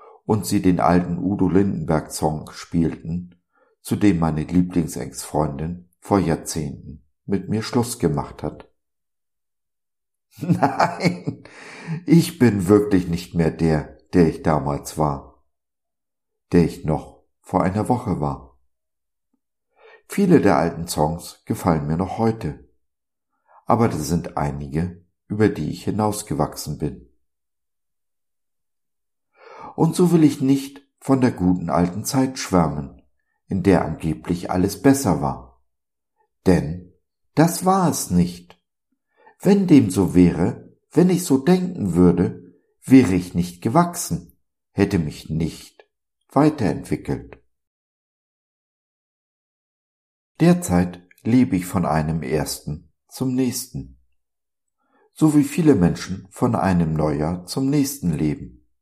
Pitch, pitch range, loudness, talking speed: 90 Hz, 75-125 Hz, -20 LUFS, 110 wpm